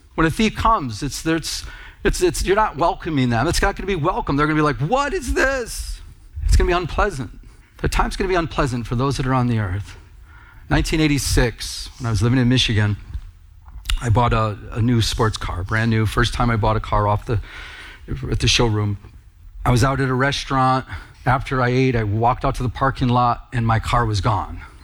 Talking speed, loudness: 220 wpm, -20 LUFS